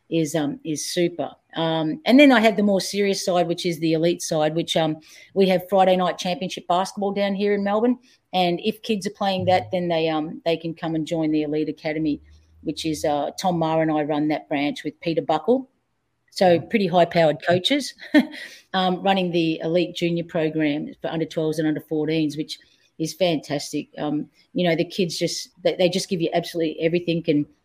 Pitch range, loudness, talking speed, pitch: 155-190 Hz, -22 LUFS, 200 wpm, 170 Hz